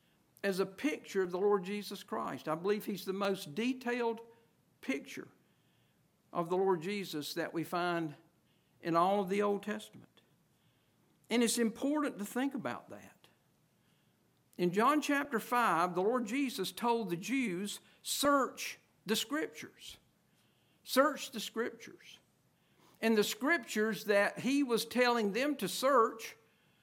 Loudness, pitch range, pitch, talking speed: -34 LUFS, 185-240 Hz, 210 Hz, 135 wpm